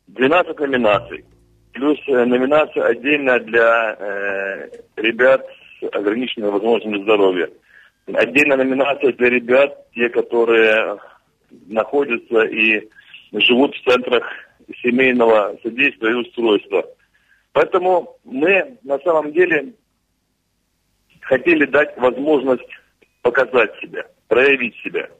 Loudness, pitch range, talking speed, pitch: -17 LUFS, 115-185 Hz, 95 wpm, 130 Hz